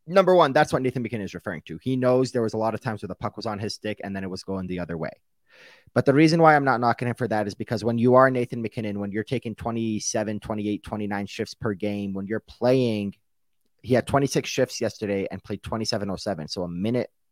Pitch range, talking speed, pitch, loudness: 100-125 Hz, 250 wpm, 110 Hz, -25 LUFS